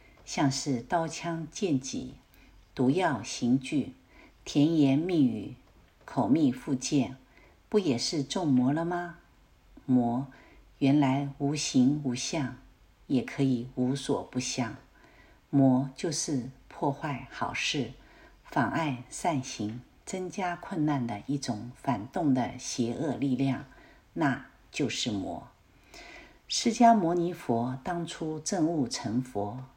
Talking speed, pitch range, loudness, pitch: 160 characters per minute, 130-165 Hz, -29 LUFS, 140 Hz